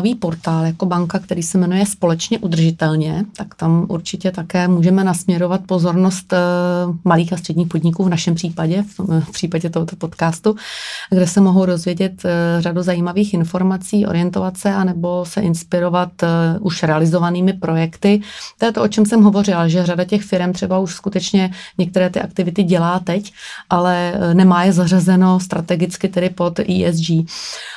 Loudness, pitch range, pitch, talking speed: -16 LUFS, 175-190 Hz, 180 Hz, 145 wpm